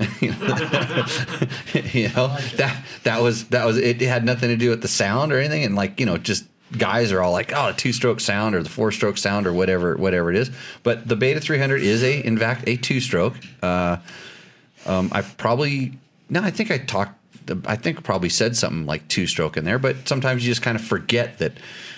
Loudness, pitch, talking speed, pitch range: -21 LUFS, 120 Hz, 215 wpm, 100-130 Hz